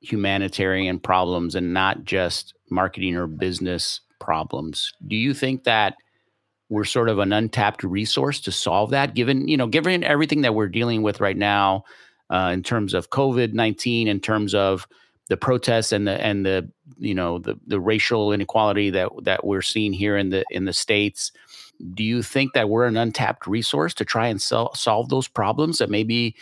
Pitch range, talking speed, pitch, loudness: 95-120 Hz, 180 wpm, 105 Hz, -22 LUFS